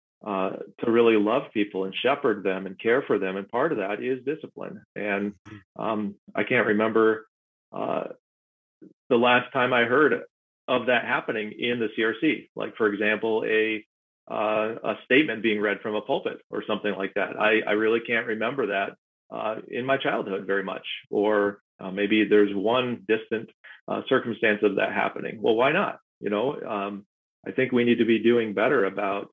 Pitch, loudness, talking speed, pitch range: 110 Hz, -25 LUFS, 180 wpm, 100-115 Hz